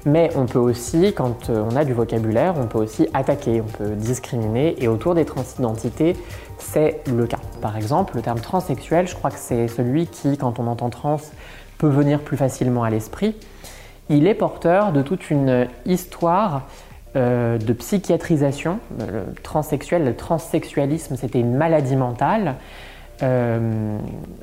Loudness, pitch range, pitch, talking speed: -21 LUFS, 120-155 Hz, 130 Hz, 155 wpm